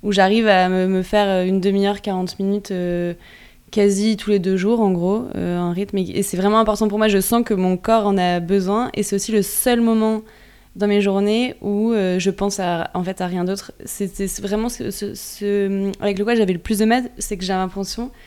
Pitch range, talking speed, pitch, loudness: 190-215 Hz, 230 wpm, 200 Hz, -19 LUFS